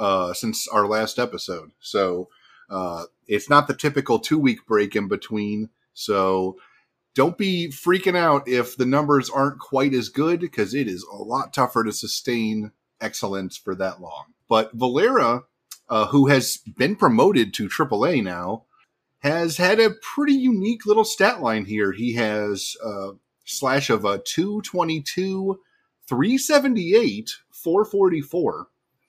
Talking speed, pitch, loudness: 140 wpm, 140 Hz, -22 LUFS